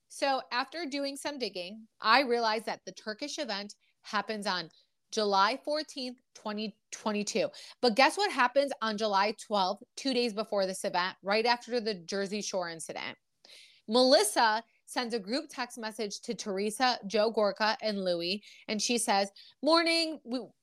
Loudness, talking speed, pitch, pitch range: -30 LUFS, 150 wpm, 220 Hz, 205-255 Hz